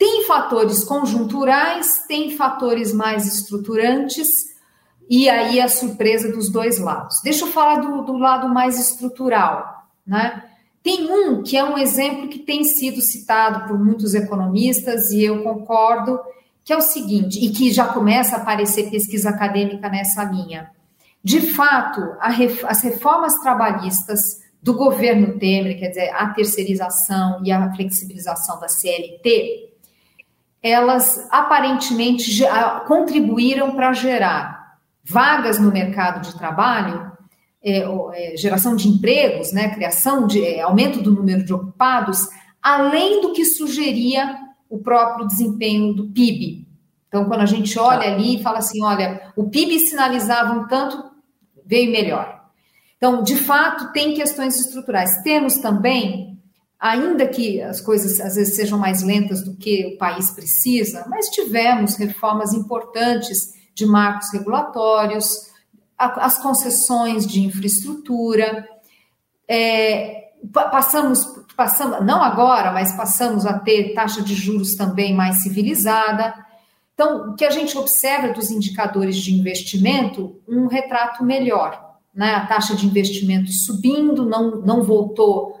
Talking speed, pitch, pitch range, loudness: 135 wpm, 225 Hz, 200-255 Hz, -17 LUFS